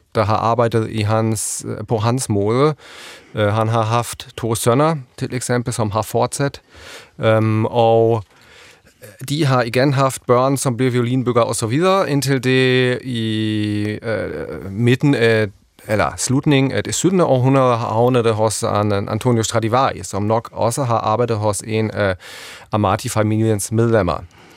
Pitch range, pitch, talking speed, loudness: 110-130 Hz, 115 Hz, 145 wpm, -18 LUFS